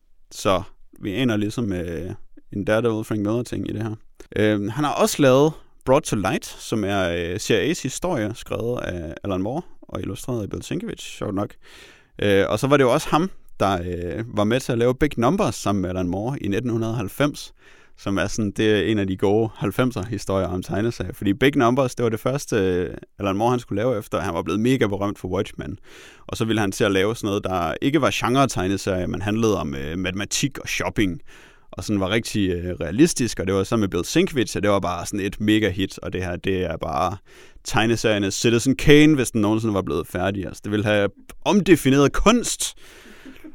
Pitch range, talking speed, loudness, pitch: 95-125 Hz, 215 wpm, -22 LUFS, 105 Hz